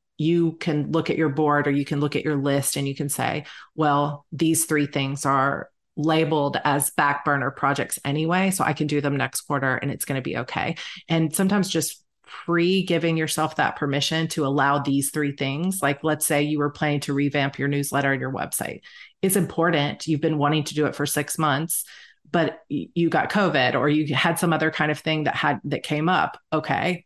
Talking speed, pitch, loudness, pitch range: 215 wpm, 150 Hz, -23 LUFS, 140-160 Hz